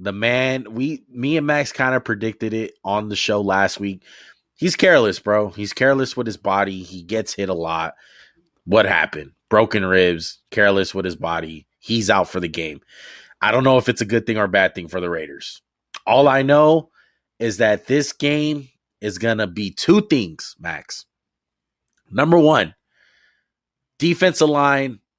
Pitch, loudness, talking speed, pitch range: 110 Hz, -19 LUFS, 170 wpm, 100-135 Hz